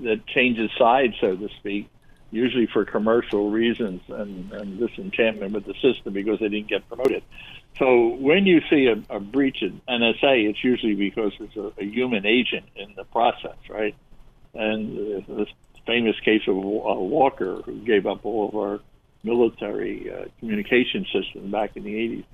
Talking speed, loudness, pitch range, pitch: 170 wpm, -23 LUFS, 105-125 Hz, 110 Hz